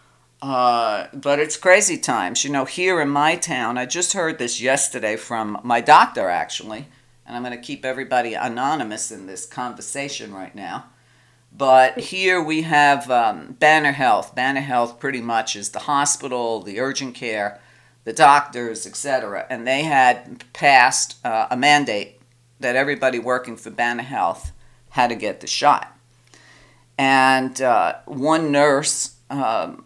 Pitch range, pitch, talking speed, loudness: 120-140 Hz, 130 Hz, 150 wpm, -19 LUFS